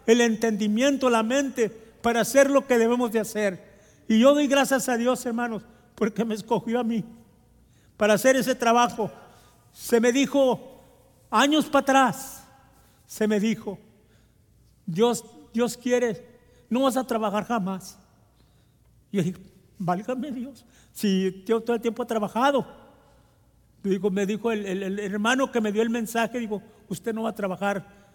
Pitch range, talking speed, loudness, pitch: 205-245 Hz, 160 wpm, -24 LUFS, 225 Hz